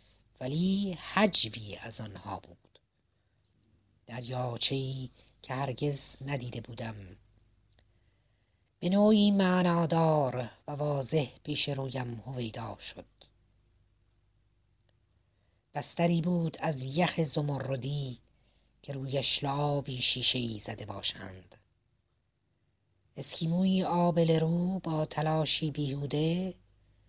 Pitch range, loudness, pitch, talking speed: 105-150 Hz, -31 LUFS, 125 Hz, 85 wpm